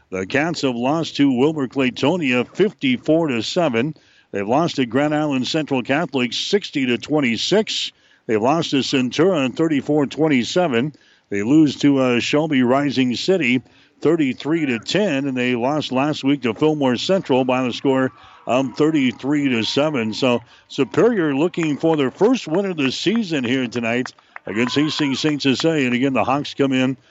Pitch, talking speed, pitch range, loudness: 135 Hz, 160 wpm, 125-155 Hz, -19 LUFS